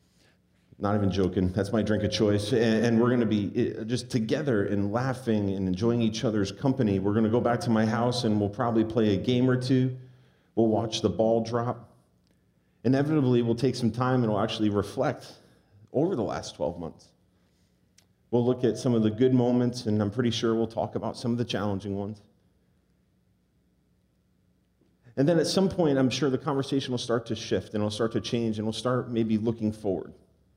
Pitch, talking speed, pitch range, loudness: 115 Hz, 200 wpm, 105-125 Hz, -27 LUFS